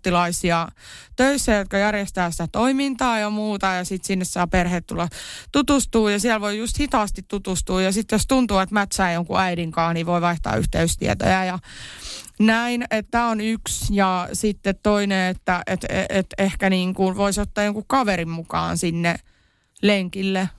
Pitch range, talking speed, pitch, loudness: 180-215 Hz, 160 wpm, 195 Hz, -21 LUFS